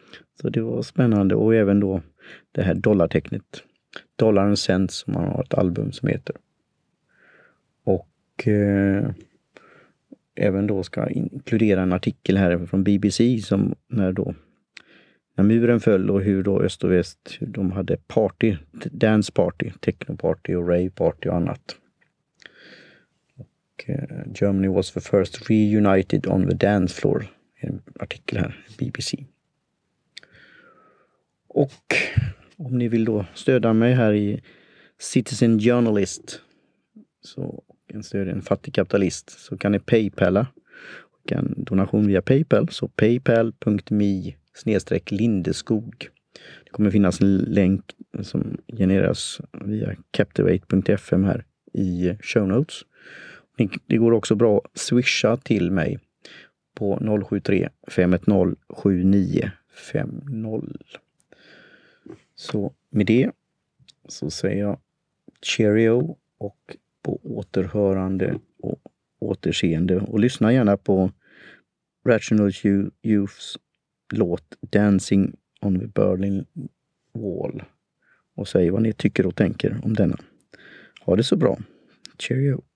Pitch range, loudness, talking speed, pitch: 95-115 Hz, -22 LUFS, 120 wpm, 100 Hz